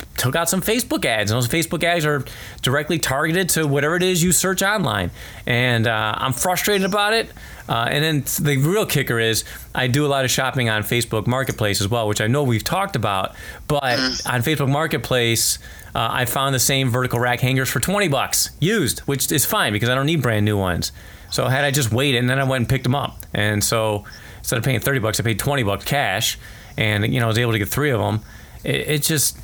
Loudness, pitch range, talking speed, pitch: -19 LUFS, 110-145 Hz, 230 wpm, 130 Hz